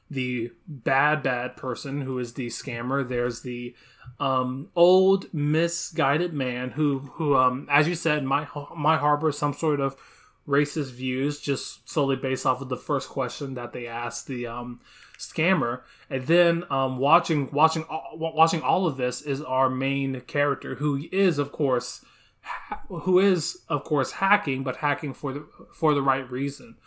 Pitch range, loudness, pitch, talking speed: 130-155 Hz, -25 LUFS, 140 Hz, 165 wpm